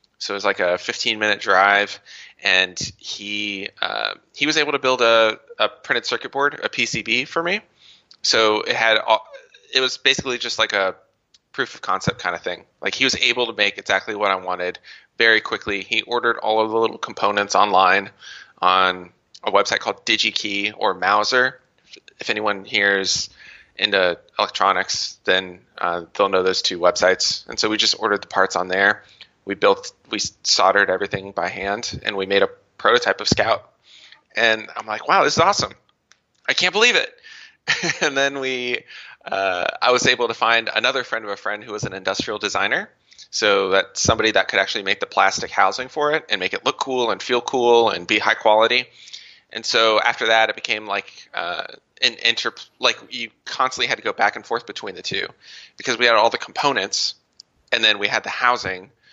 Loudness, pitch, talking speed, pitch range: -19 LUFS, 115 Hz, 195 wpm, 100-130 Hz